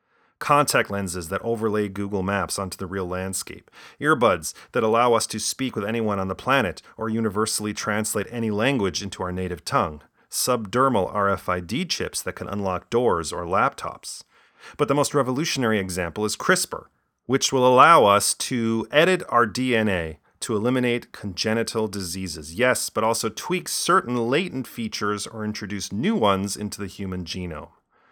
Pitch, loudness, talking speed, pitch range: 105 Hz, -23 LUFS, 155 wpm, 95-120 Hz